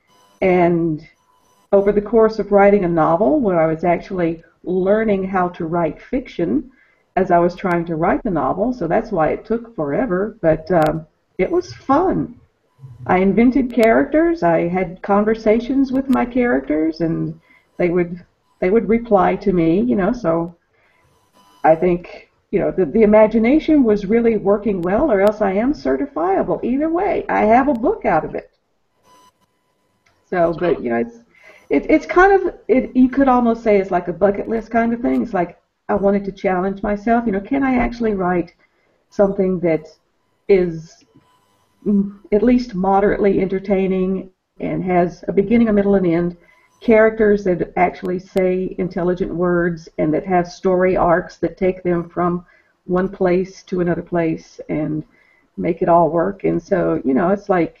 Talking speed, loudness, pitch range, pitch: 170 wpm, -17 LUFS, 170-220 Hz, 190 Hz